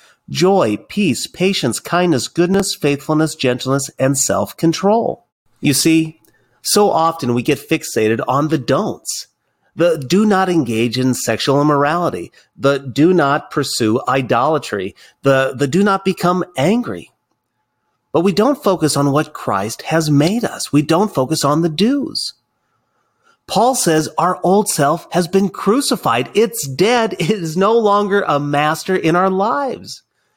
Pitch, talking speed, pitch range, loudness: 160 Hz, 145 wpm, 140-190 Hz, -16 LUFS